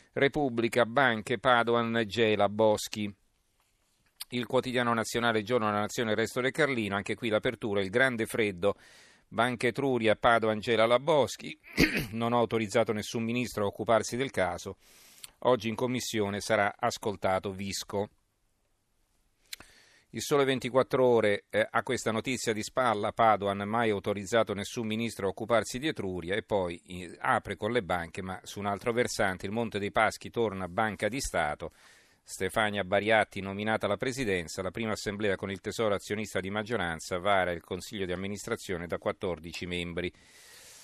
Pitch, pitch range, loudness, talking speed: 110 Hz, 100-120 Hz, -30 LUFS, 150 wpm